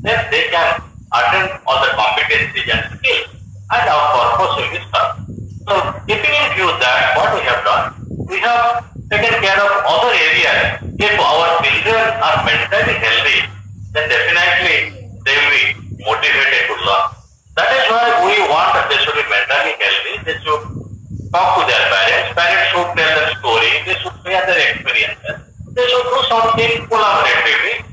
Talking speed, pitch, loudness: 165 wpm, 210 Hz, -13 LUFS